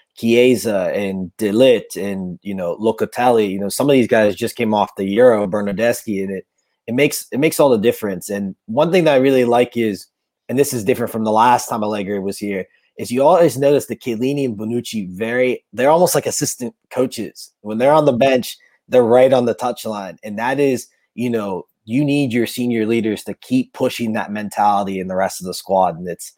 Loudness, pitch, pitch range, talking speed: -17 LUFS, 115 Hz, 100-125 Hz, 215 wpm